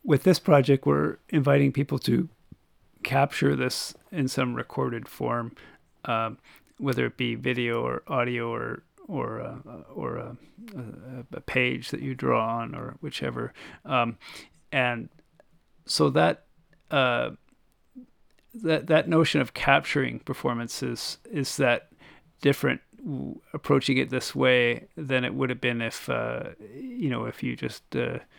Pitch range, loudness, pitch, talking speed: 120-150 Hz, -27 LUFS, 130 Hz, 135 wpm